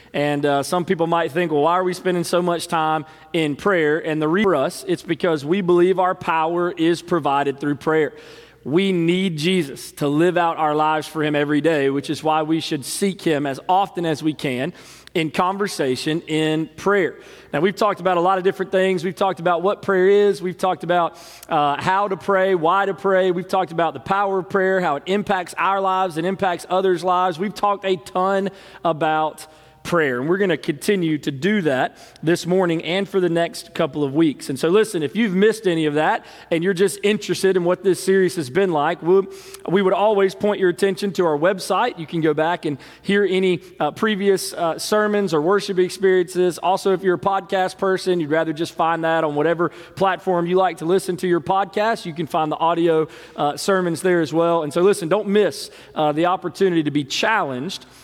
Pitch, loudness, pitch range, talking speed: 180 Hz, -20 LUFS, 160-190 Hz, 215 wpm